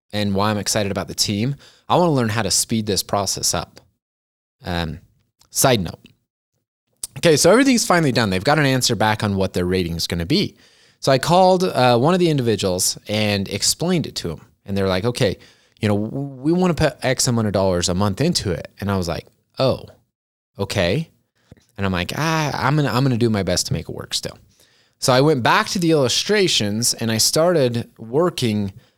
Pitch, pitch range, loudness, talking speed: 115 Hz, 100-135 Hz, -19 LUFS, 215 wpm